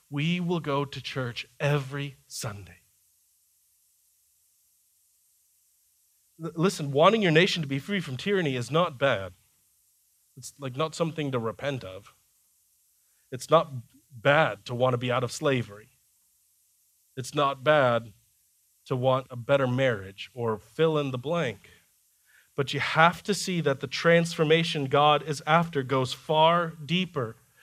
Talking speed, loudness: 135 wpm, -26 LUFS